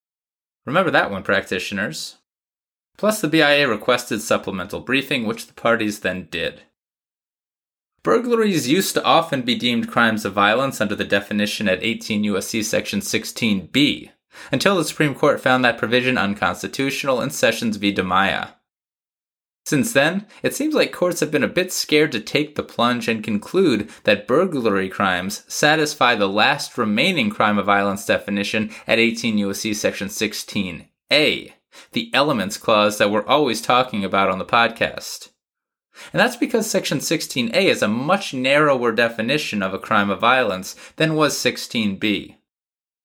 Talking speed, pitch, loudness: 150 wpm, 130 Hz, -19 LUFS